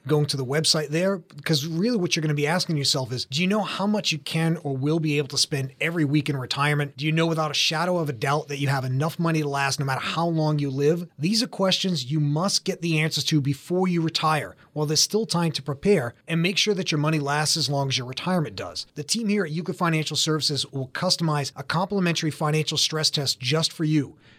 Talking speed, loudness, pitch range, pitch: 250 wpm, -24 LUFS, 145-170 Hz, 155 Hz